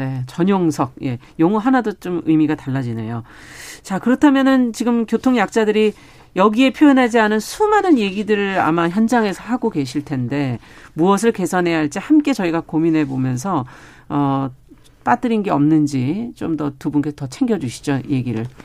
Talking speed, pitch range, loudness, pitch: 330 characters per minute, 140-225 Hz, -18 LUFS, 170 Hz